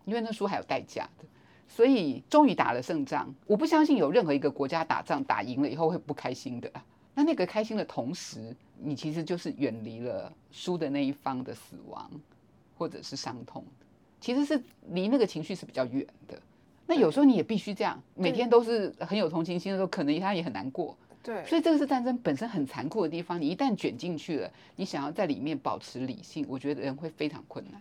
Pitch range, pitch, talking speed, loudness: 145-240 Hz, 180 Hz, 330 characters per minute, -30 LUFS